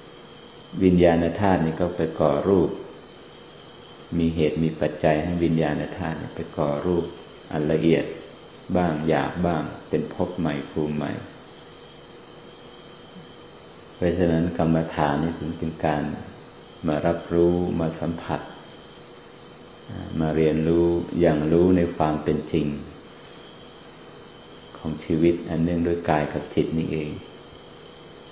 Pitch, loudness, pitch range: 80 Hz, -24 LUFS, 75-85 Hz